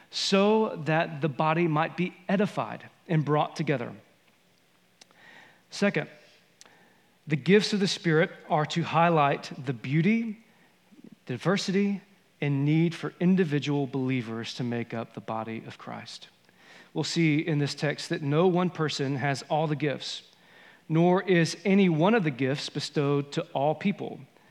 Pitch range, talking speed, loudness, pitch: 145-190 Hz, 140 wpm, -27 LUFS, 160 Hz